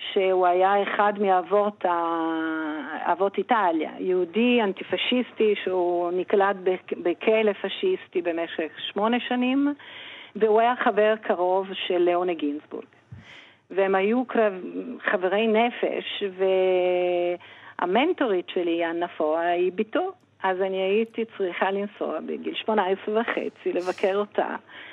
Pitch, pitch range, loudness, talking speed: 195 Hz, 180-220 Hz, -24 LUFS, 105 wpm